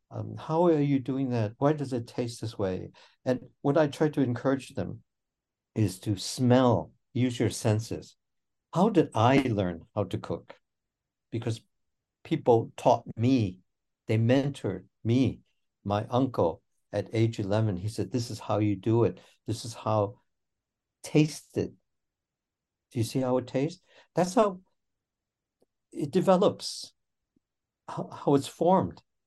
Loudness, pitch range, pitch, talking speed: -28 LUFS, 105-135 Hz, 120 Hz, 145 wpm